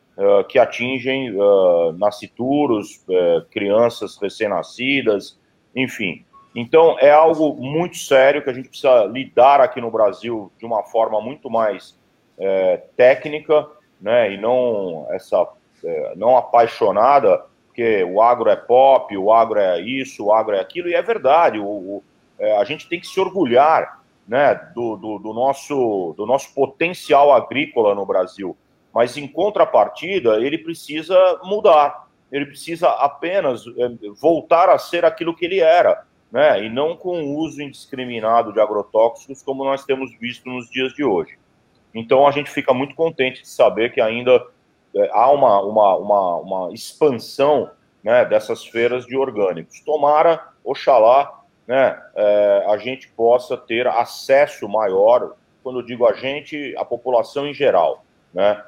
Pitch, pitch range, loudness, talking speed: 140 Hz, 125-175 Hz, -17 LUFS, 150 wpm